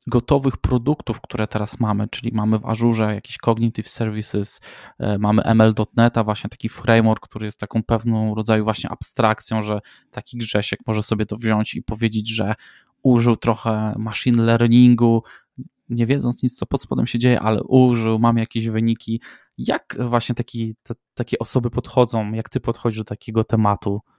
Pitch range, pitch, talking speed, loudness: 110-120 Hz, 115 Hz, 160 wpm, -20 LUFS